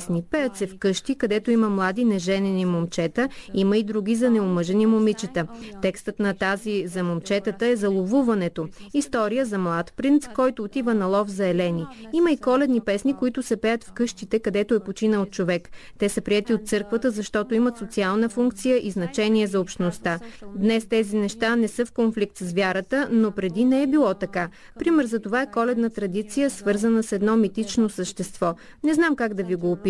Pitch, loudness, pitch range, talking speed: 215 Hz, -23 LUFS, 195-235 Hz, 185 wpm